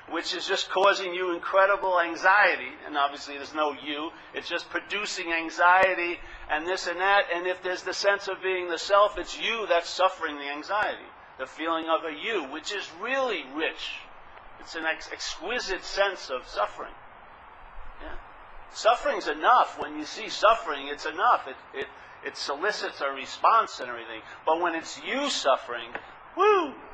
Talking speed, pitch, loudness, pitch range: 165 wpm, 180 Hz, -26 LUFS, 160-195 Hz